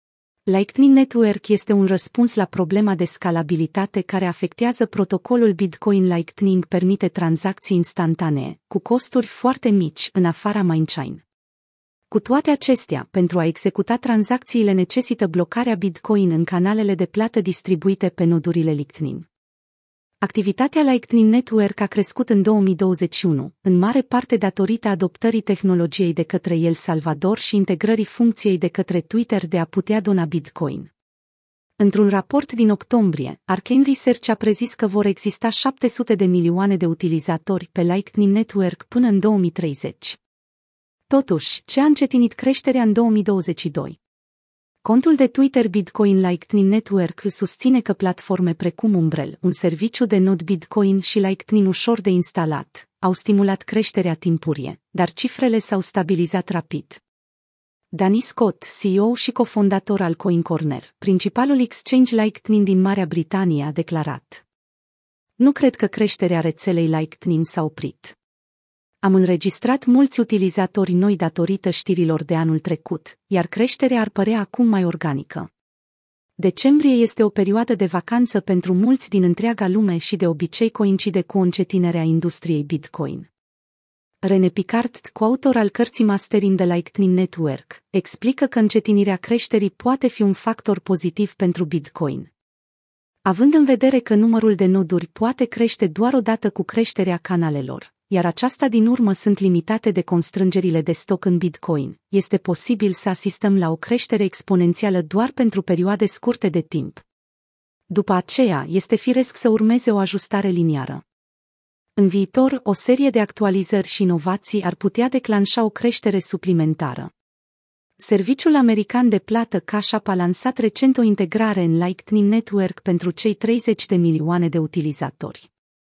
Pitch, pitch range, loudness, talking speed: 195 Hz, 175-225 Hz, -19 LUFS, 140 wpm